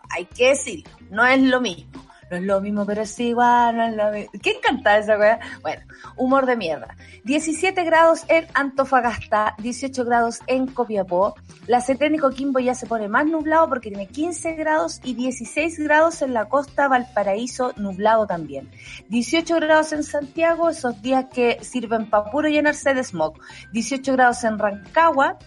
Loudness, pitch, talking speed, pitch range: -20 LUFS, 250 Hz, 175 wpm, 215-300 Hz